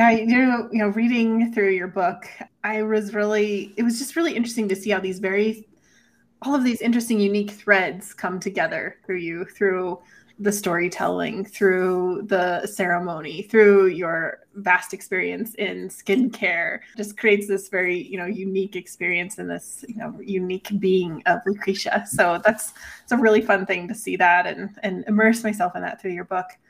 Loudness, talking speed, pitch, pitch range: -22 LUFS, 175 wpm, 200 Hz, 185-220 Hz